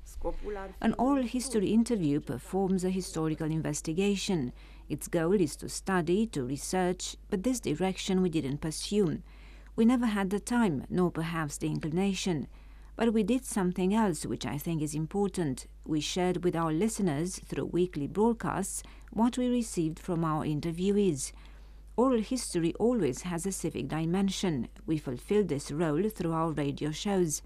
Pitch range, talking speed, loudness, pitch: 155-205 Hz, 150 wpm, -31 LUFS, 180 Hz